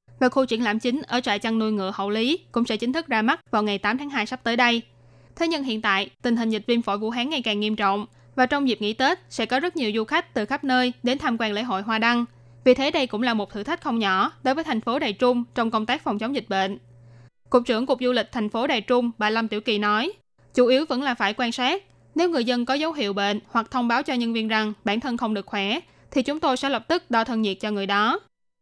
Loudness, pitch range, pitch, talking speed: -24 LUFS, 210-255 Hz, 235 Hz, 285 wpm